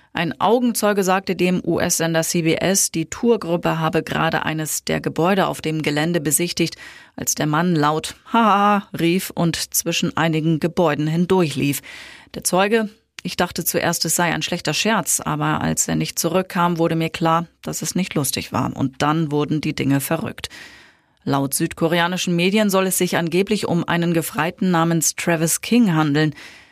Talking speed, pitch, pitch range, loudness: 160 wpm, 165 Hz, 155-185 Hz, -19 LUFS